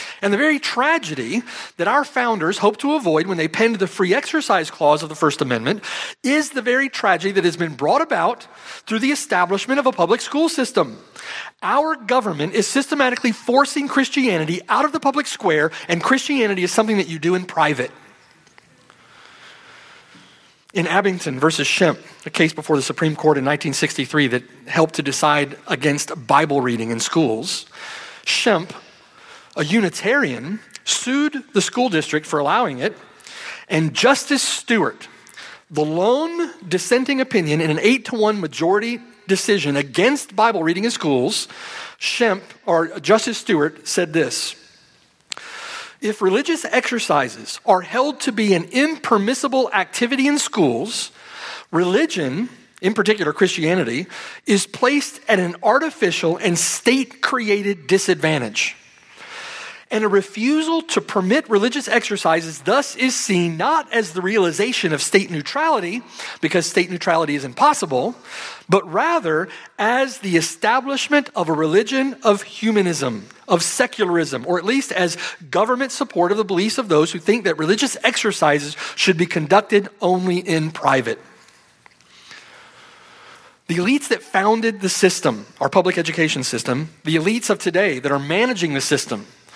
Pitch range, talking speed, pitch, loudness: 165-255 Hz, 145 wpm, 200 Hz, -19 LUFS